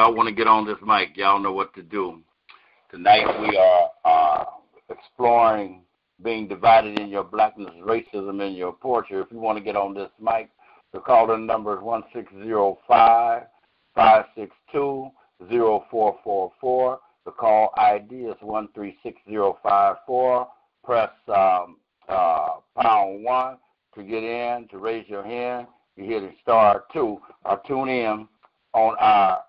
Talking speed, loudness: 165 wpm, -21 LUFS